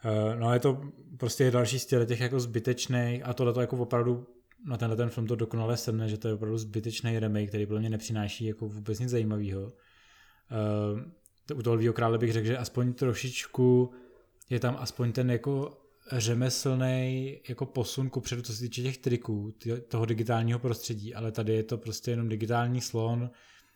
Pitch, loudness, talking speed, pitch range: 120 Hz, -31 LUFS, 180 wpm, 115-125 Hz